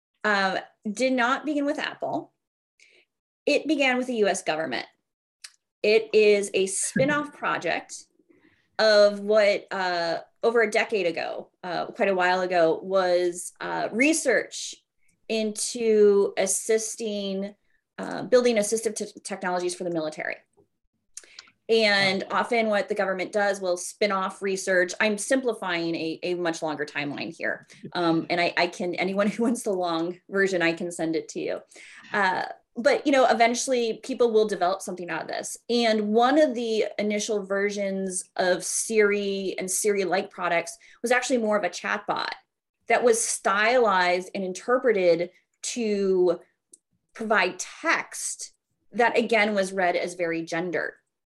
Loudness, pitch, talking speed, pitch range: -25 LUFS, 200 Hz, 145 wpm, 180-225 Hz